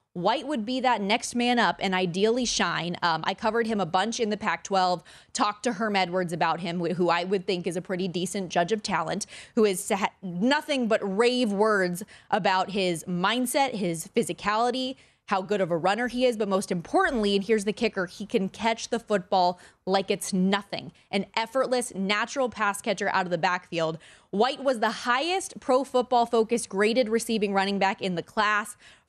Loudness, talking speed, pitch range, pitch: -26 LUFS, 195 wpm, 185-235 Hz, 205 Hz